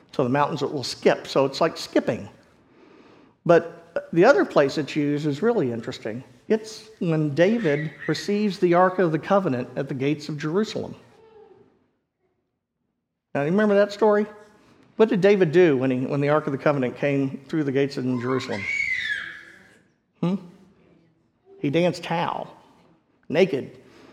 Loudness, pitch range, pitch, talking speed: -23 LUFS, 145-205 Hz, 165 Hz, 150 wpm